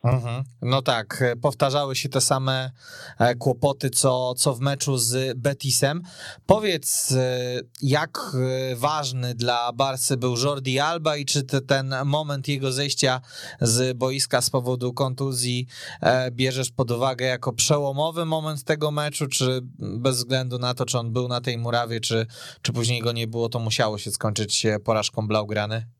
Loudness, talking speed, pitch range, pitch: -23 LUFS, 150 wpm, 125-140 Hz, 130 Hz